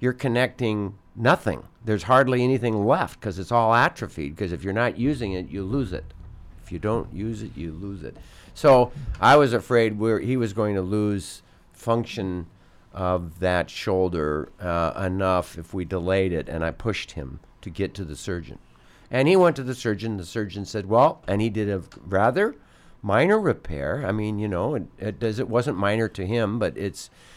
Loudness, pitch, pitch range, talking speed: -24 LUFS, 105 Hz, 90-115 Hz, 195 wpm